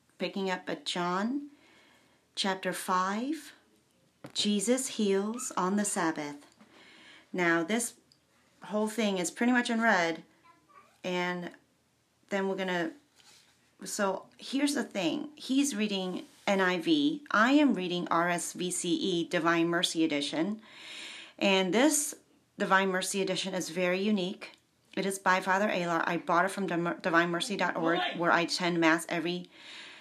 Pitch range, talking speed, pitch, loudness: 175-230 Hz, 125 wpm, 190 Hz, -30 LUFS